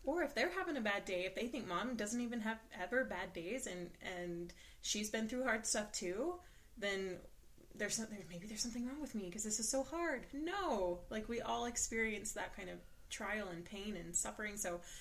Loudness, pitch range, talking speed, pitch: -41 LUFS, 180-240 Hz, 210 wpm, 210 Hz